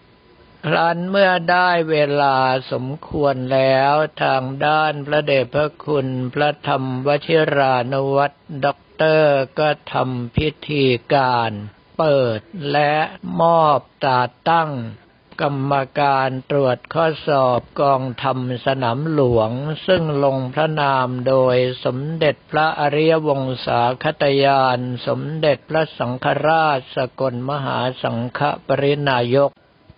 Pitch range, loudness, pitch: 130-150 Hz, -18 LUFS, 140 Hz